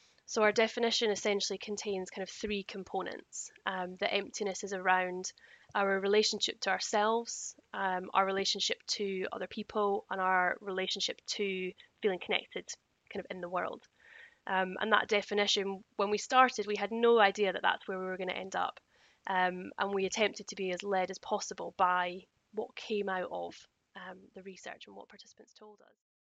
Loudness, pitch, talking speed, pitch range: -33 LUFS, 200 Hz, 180 wpm, 185-210 Hz